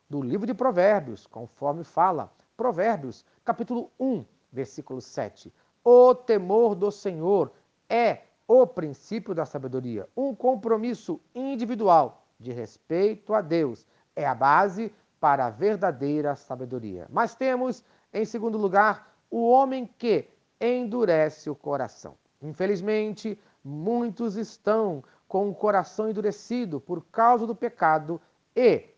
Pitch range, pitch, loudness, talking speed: 150-235 Hz, 205 Hz, -25 LUFS, 120 wpm